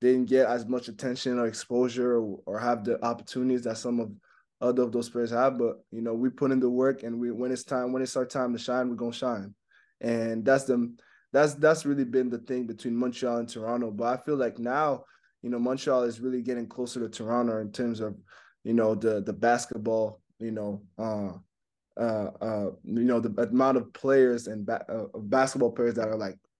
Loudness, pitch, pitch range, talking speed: -28 LUFS, 120 Hz, 115-125 Hz, 220 wpm